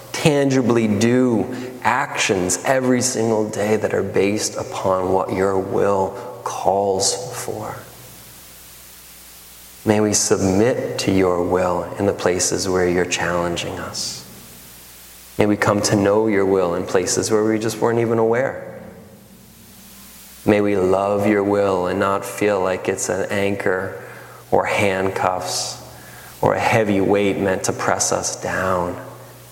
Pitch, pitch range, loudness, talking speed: 100 Hz, 90-110 Hz, -19 LUFS, 135 wpm